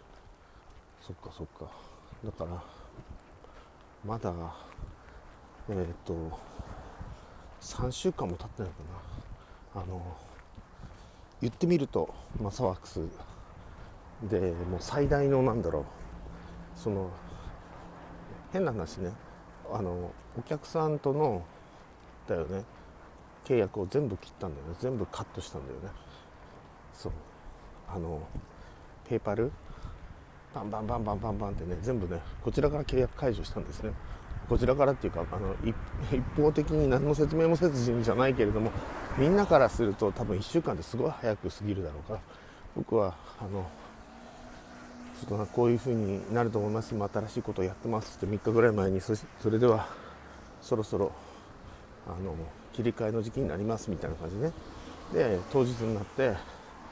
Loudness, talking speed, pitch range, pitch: -31 LUFS, 285 characters per minute, 90-120 Hz, 100 Hz